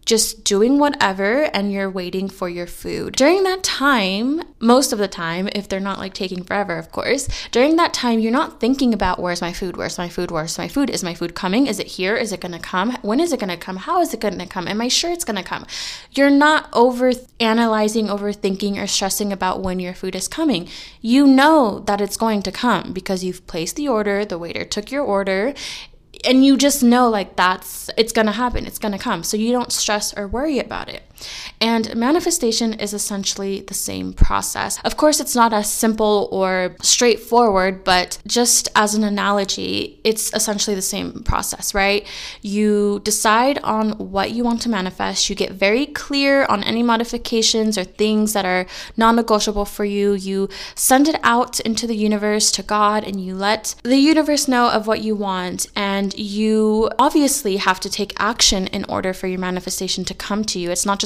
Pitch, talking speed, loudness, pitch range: 210 Hz, 200 wpm, -18 LUFS, 195-240 Hz